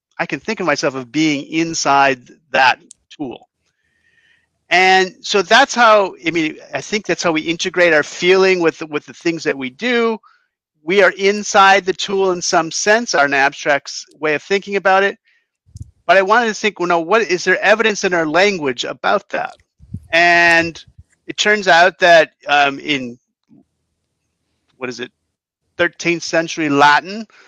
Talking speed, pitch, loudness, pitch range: 170 wpm, 180 Hz, -14 LUFS, 155-210 Hz